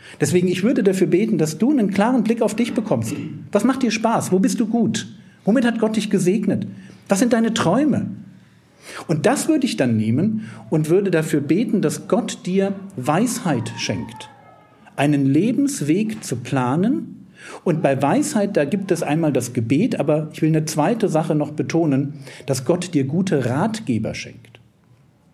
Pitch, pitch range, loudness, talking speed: 185 Hz, 150-225 Hz, -20 LUFS, 170 wpm